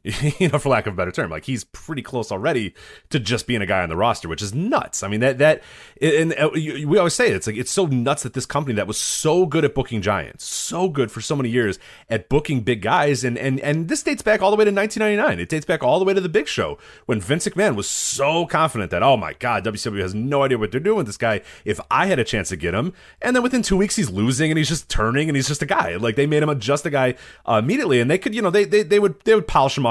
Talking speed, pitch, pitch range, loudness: 290 wpm, 145 Hz, 115-180 Hz, -20 LUFS